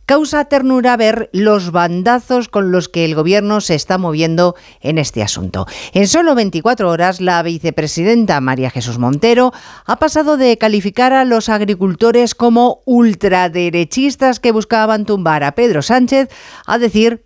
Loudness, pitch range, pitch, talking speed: -13 LUFS, 175-240 Hz, 210 Hz, 145 wpm